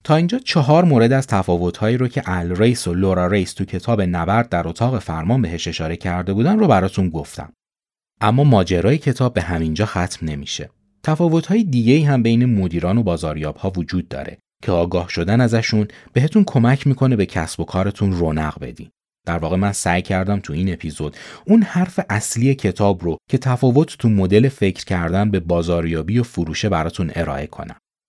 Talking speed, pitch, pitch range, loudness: 175 wpm, 100 Hz, 85-125 Hz, -18 LUFS